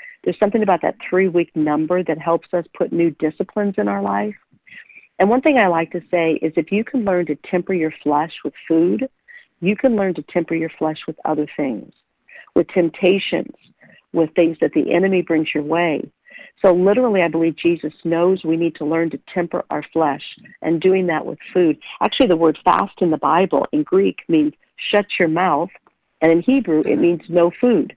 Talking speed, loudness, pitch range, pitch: 195 wpm, -18 LUFS, 160-190 Hz, 170 Hz